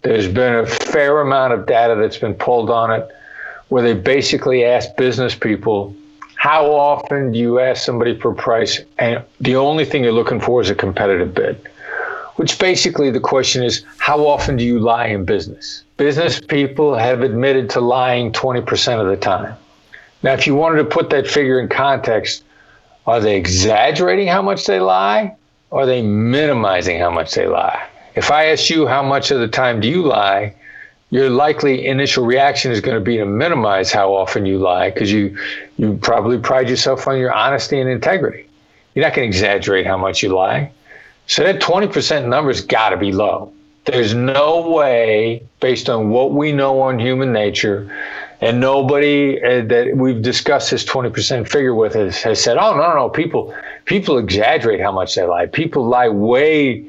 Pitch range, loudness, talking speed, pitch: 115-145 Hz, -15 LUFS, 185 wpm, 130 Hz